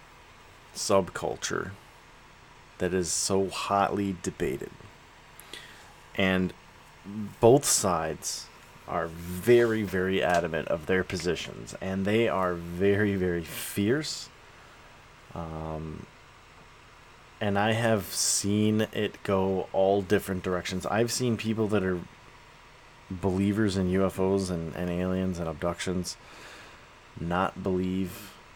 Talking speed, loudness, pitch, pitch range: 100 wpm, -28 LUFS, 95 Hz, 90-100 Hz